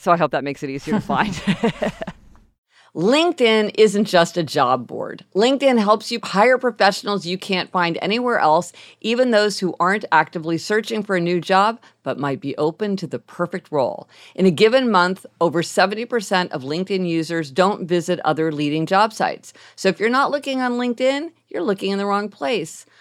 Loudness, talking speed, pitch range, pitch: -19 LUFS, 185 wpm, 170-220 Hz, 190 Hz